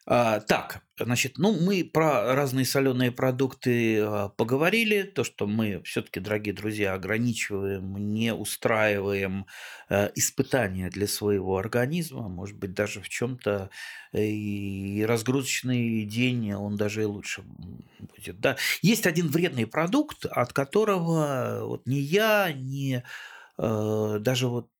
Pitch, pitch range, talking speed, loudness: 115 Hz, 105-135 Hz, 115 wpm, -27 LUFS